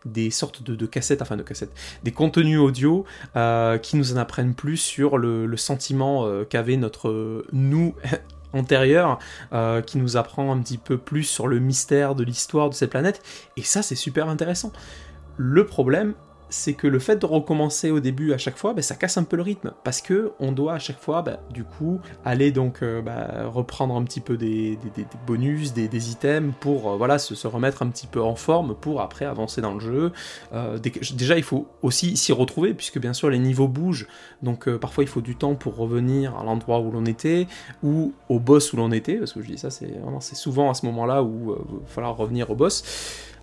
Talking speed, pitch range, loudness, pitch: 225 wpm, 115-150 Hz, -23 LUFS, 135 Hz